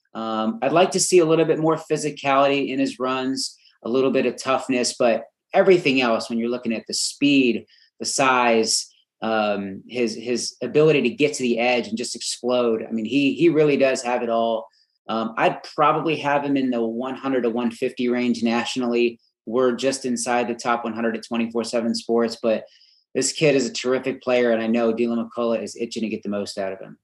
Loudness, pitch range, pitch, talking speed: -22 LUFS, 115-135 Hz, 120 Hz, 205 wpm